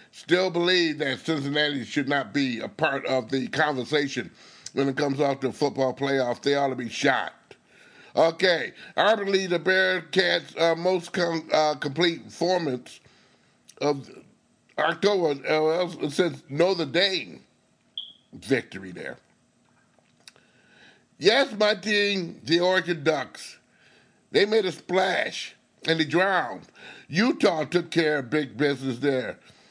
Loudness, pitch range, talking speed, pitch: -25 LUFS, 140-180 Hz, 130 wpm, 155 Hz